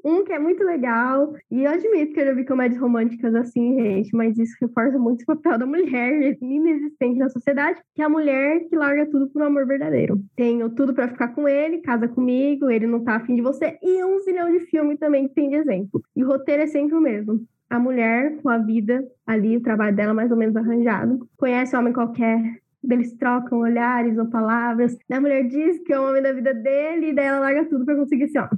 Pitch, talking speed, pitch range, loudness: 265 Hz, 235 wpm, 235-295 Hz, -21 LUFS